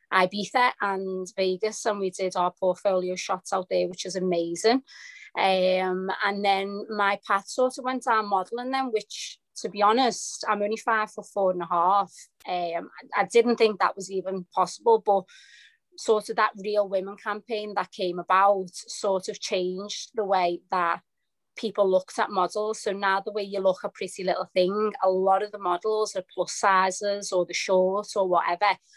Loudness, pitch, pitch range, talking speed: -26 LUFS, 195 Hz, 185-210 Hz, 180 wpm